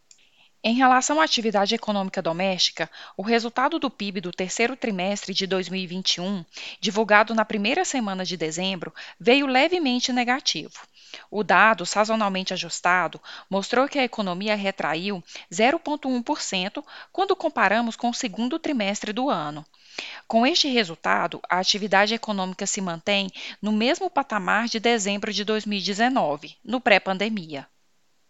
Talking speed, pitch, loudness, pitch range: 125 wpm, 215 Hz, -23 LUFS, 190-245 Hz